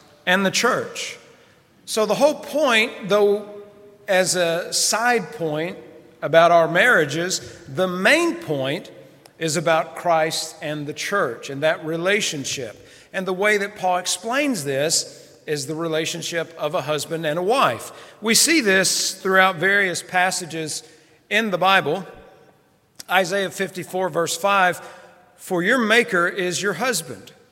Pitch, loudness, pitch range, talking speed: 180 Hz, -20 LUFS, 160-205 Hz, 135 wpm